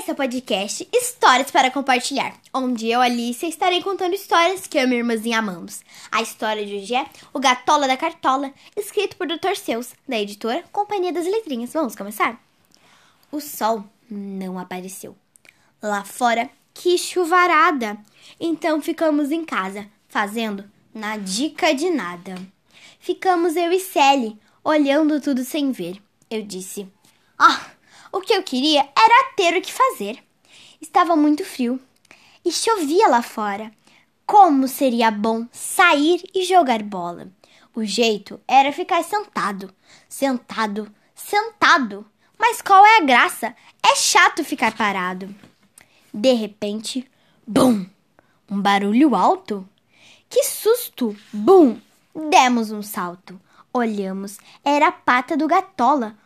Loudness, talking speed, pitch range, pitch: -19 LUFS, 130 wpm, 215-345 Hz, 260 Hz